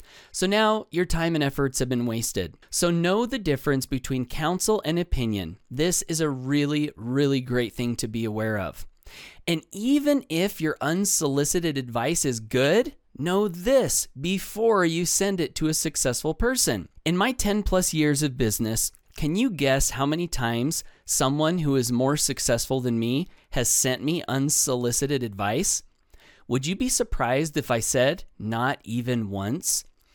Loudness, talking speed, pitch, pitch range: -25 LUFS, 160 wpm, 145 Hz, 125-175 Hz